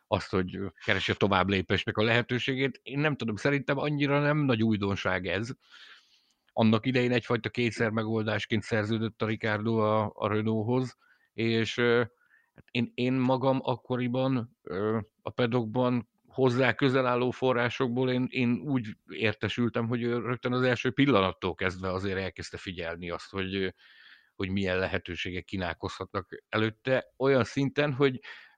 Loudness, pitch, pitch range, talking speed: -29 LUFS, 115 Hz, 105-125 Hz, 130 wpm